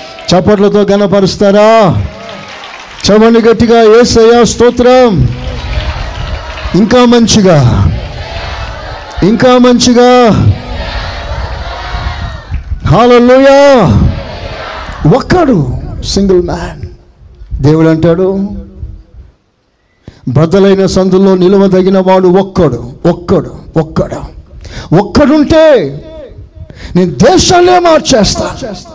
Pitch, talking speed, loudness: 190 Hz, 60 wpm, -7 LUFS